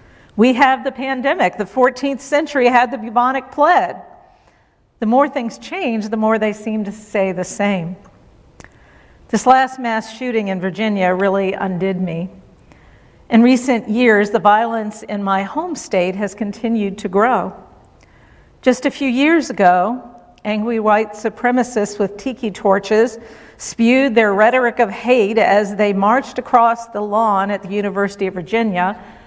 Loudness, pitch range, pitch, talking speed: -16 LUFS, 200-250 Hz, 225 Hz, 150 wpm